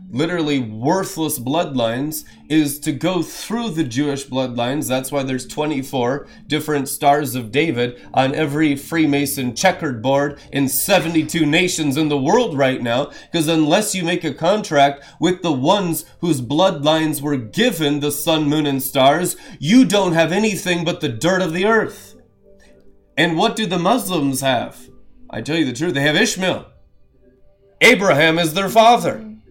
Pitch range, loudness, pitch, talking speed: 140-175 Hz, -18 LUFS, 155 Hz, 155 wpm